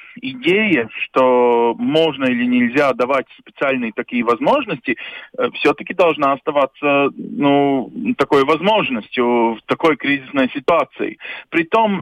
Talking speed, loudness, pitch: 105 wpm, -17 LUFS, 145 Hz